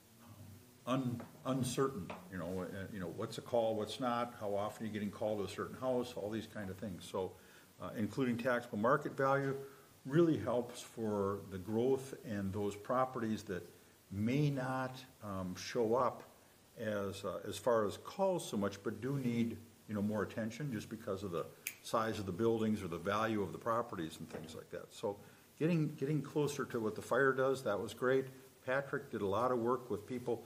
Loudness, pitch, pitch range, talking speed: -38 LUFS, 115 Hz, 105-130 Hz, 195 wpm